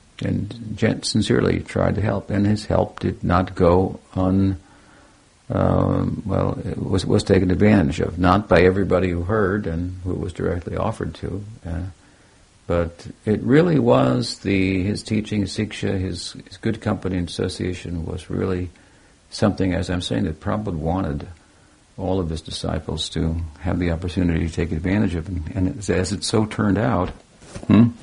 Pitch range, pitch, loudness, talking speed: 90-105 Hz, 95 Hz, -22 LUFS, 165 wpm